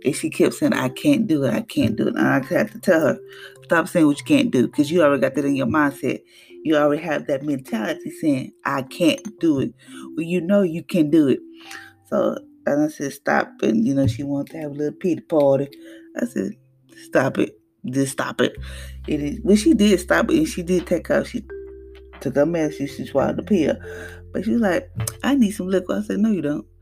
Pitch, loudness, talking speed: 160 Hz, -21 LUFS, 235 wpm